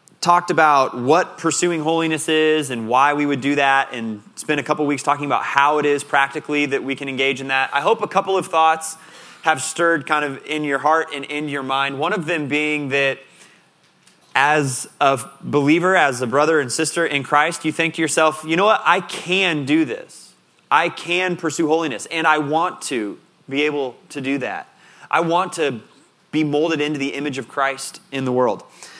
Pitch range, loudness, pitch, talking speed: 140-165 Hz, -19 LUFS, 150 Hz, 205 wpm